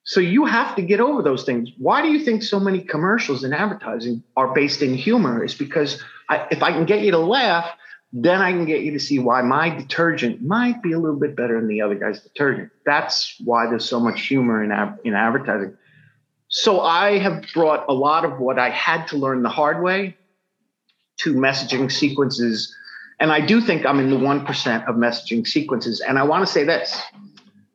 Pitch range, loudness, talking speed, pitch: 130-195 Hz, -19 LUFS, 210 wpm, 150 Hz